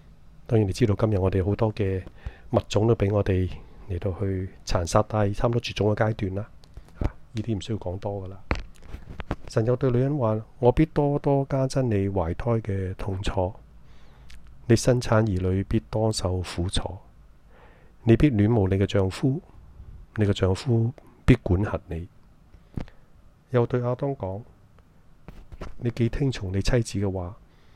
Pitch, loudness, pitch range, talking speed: 100 Hz, -25 LUFS, 95-115 Hz, 215 characters per minute